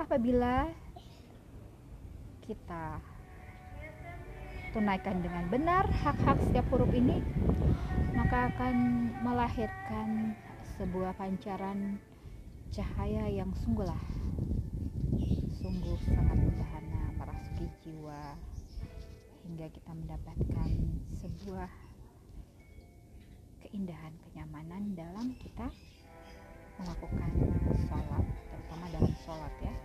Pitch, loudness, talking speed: 110 Hz, -34 LUFS, 70 wpm